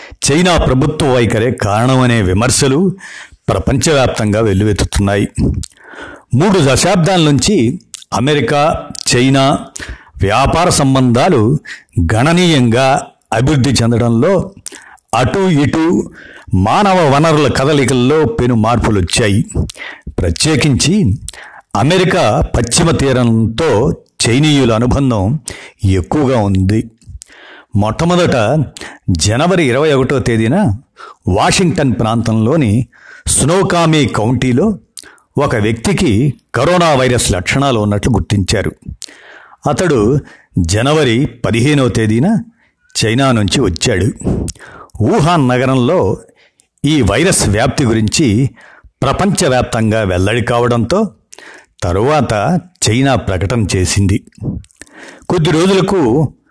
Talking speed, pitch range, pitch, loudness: 75 wpm, 110-150 Hz, 125 Hz, -12 LUFS